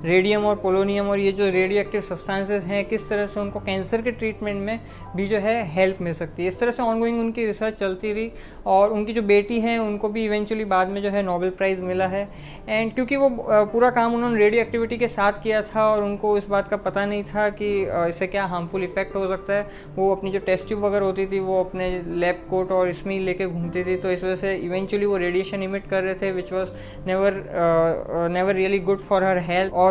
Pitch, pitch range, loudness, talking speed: 195 Hz, 185-210 Hz, -23 LUFS, 235 wpm